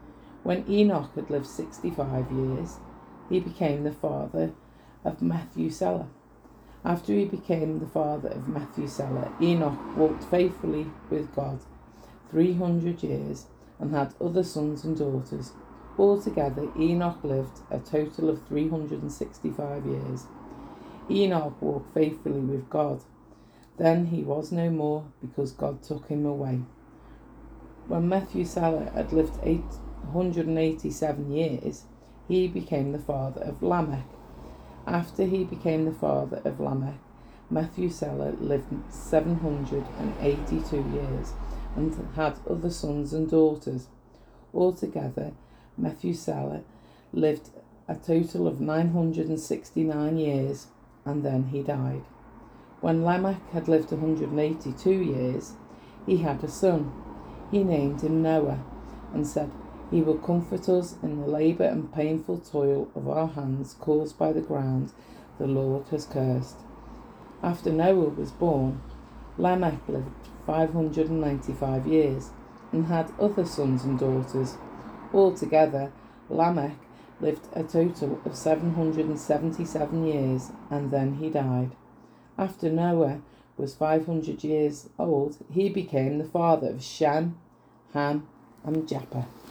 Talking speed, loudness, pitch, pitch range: 120 wpm, -28 LUFS, 150 Hz, 135-165 Hz